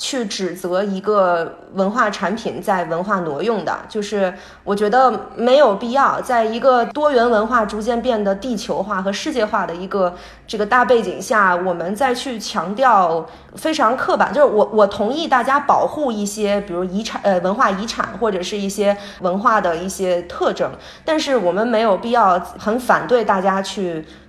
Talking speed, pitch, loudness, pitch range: 265 characters per minute, 210 Hz, -18 LUFS, 190-245 Hz